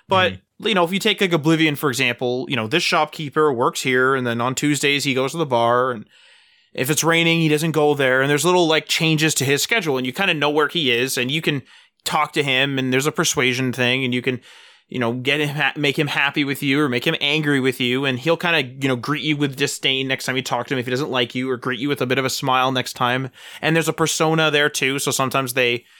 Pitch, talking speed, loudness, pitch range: 140 Hz, 275 wpm, -19 LUFS, 130-155 Hz